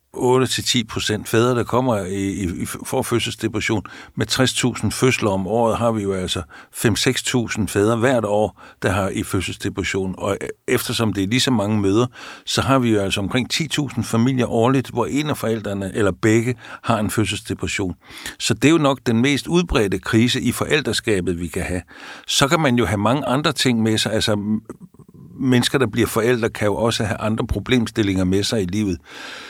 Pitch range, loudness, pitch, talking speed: 100-125 Hz, -20 LUFS, 115 Hz, 180 wpm